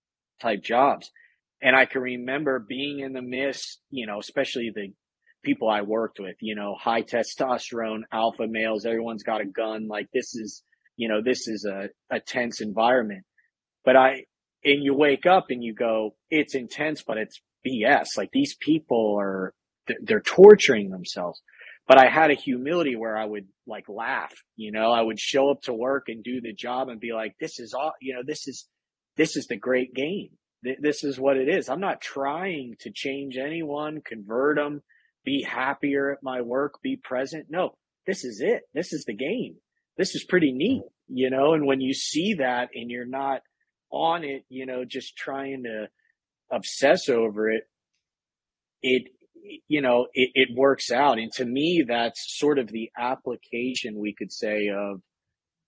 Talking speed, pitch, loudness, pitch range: 180 wpm, 130 Hz, -24 LUFS, 115-145 Hz